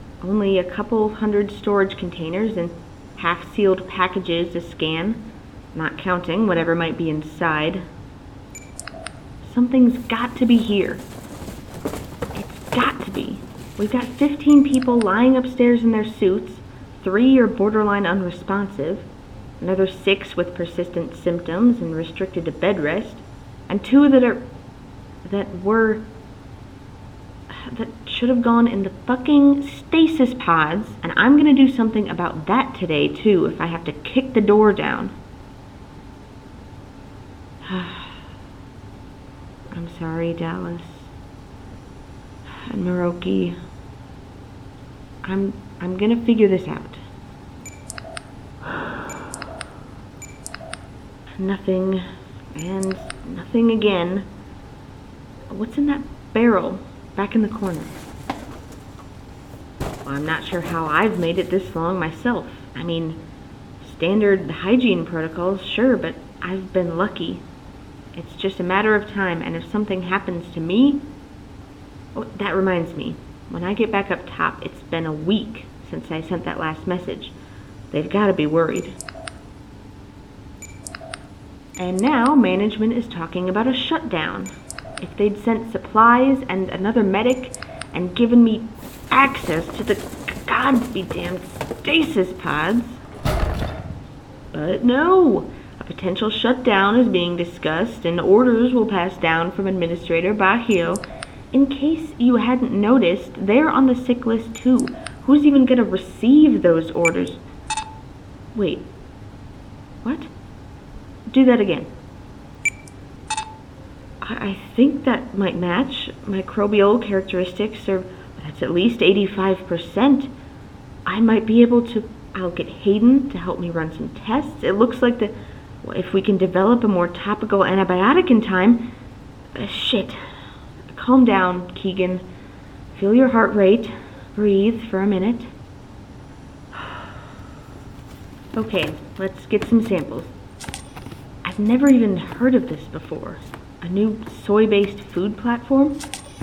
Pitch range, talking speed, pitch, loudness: 165-230 Hz, 120 wpm, 195 Hz, -19 LUFS